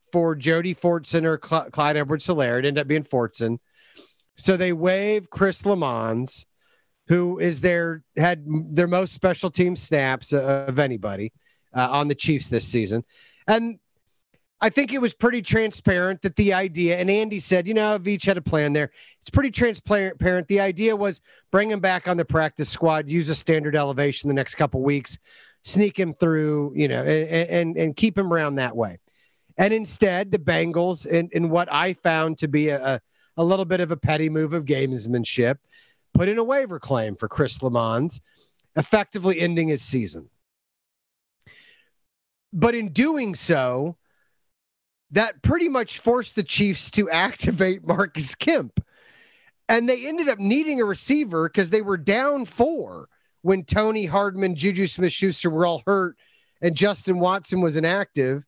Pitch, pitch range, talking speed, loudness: 175 Hz, 150-200 Hz, 165 wpm, -22 LUFS